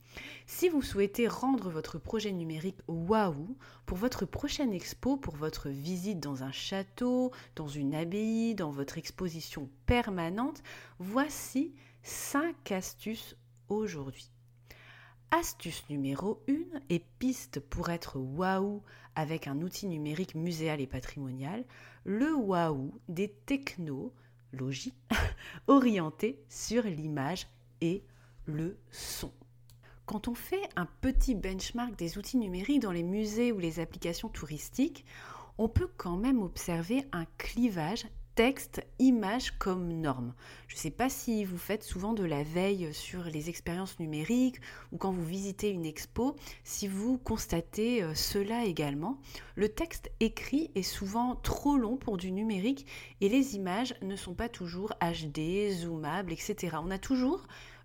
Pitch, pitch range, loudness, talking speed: 190 Hz, 155-230 Hz, -34 LUFS, 135 wpm